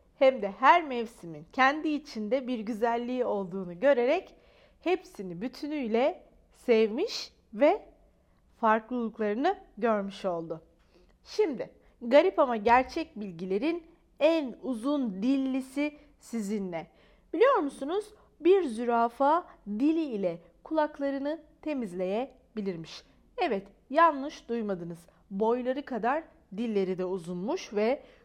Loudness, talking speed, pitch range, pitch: -29 LUFS, 90 wpm, 210-300 Hz, 250 Hz